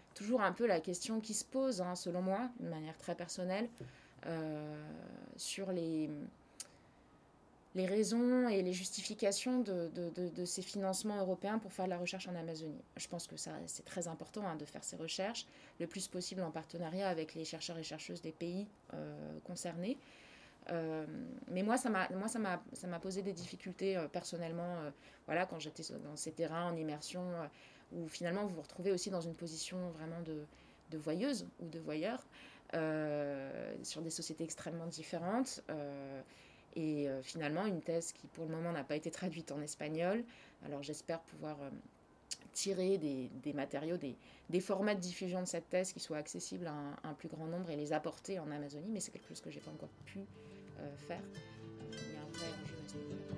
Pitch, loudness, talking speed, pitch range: 170 Hz, -41 LUFS, 190 wpm, 155-190 Hz